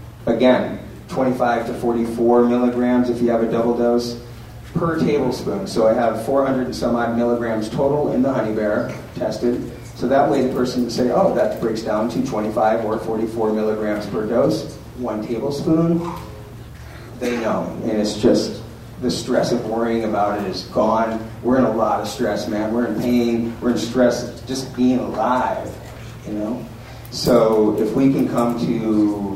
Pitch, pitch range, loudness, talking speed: 120 Hz, 110-125 Hz, -20 LUFS, 170 wpm